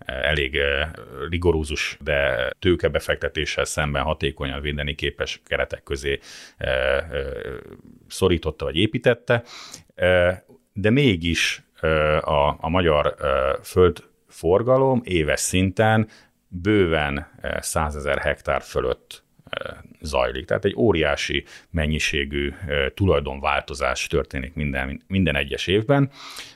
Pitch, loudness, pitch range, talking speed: 85 Hz, -22 LUFS, 75-120 Hz, 80 wpm